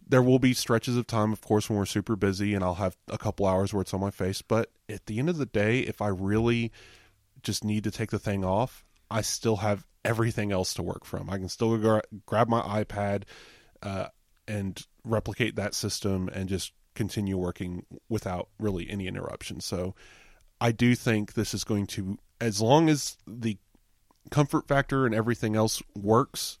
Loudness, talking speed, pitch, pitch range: -28 LUFS, 195 wpm, 105 Hz, 95-115 Hz